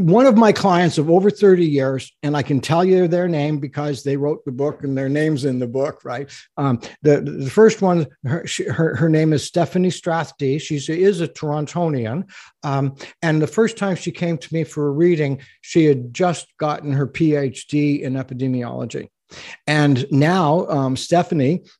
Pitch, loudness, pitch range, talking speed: 150 Hz, -19 LUFS, 140-175 Hz, 185 wpm